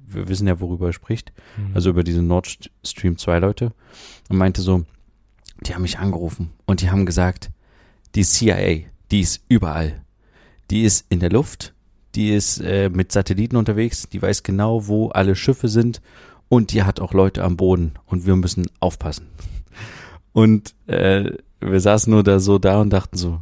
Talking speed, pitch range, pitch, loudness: 175 wpm, 90-105 Hz, 95 Hz, -19 LUFS